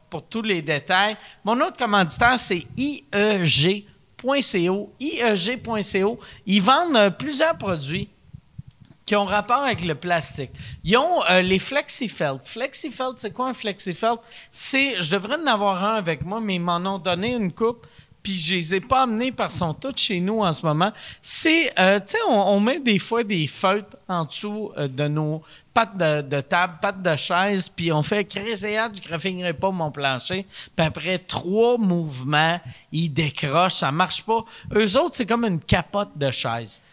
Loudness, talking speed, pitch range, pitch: -22 LUFS, 175 wpm, 170-230 Hz, 195 Hz